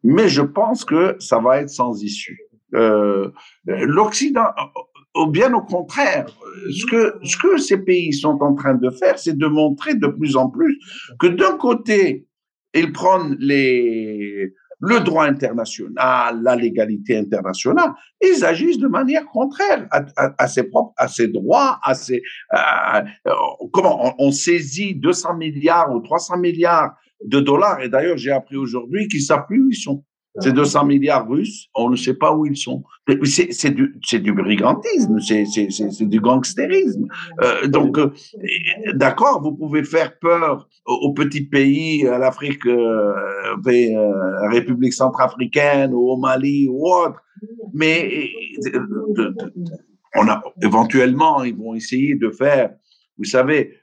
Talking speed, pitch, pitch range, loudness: 155 wpm, 150 Hz, 130-210 Hz, -17 LUFS